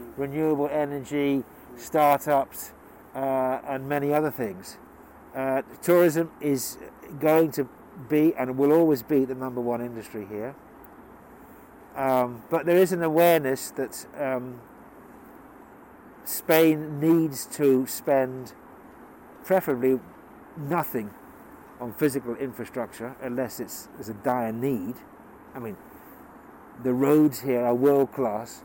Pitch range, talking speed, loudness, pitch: 125-150 Hz, 115 wpm, -25 LUFS, 135 Hz